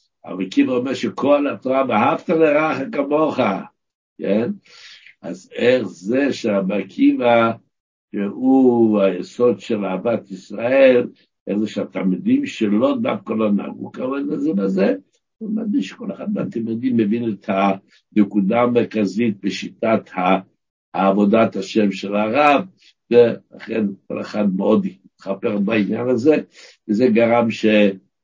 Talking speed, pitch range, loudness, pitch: 115 wpm, 100-145 Hz, -19 LUFS, 115 Hz